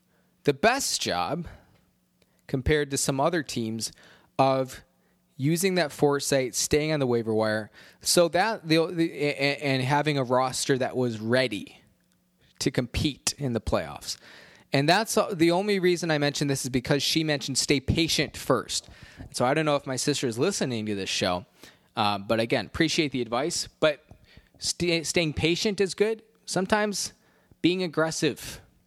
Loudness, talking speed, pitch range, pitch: -26 LUFS, 155 wpm, 125-165 Hz, 145 Hz